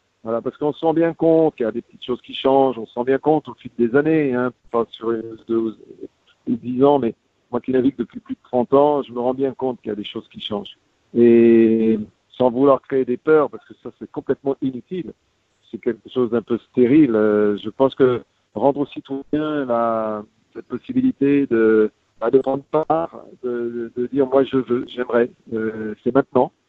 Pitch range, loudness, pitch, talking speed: 115-140 Hz, -19 LUFS, 125 Hz, 210 wpm